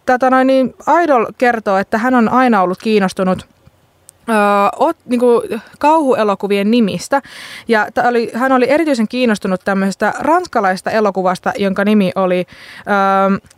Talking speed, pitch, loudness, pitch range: 130 wpm, 220 Hz, -14 LUFS, 195-255 Hz